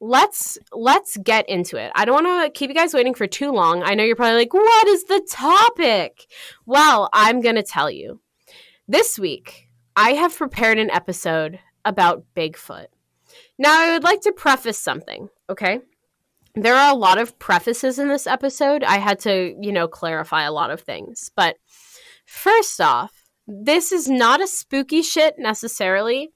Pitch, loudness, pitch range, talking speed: 265 Hz, -18 LUFS, 210-335 Hz, 175 wpm